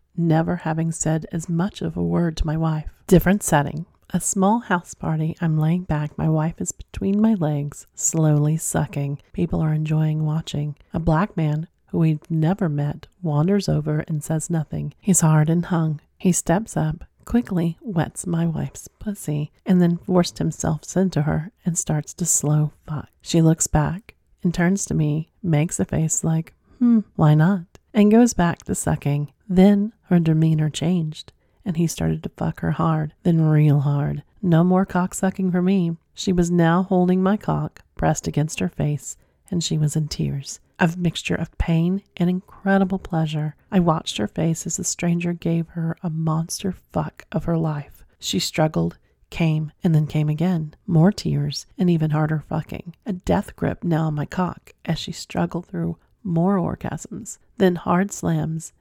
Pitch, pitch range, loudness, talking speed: 165 Hz, 155-180 Hz, -22 LUFS, 175 wpm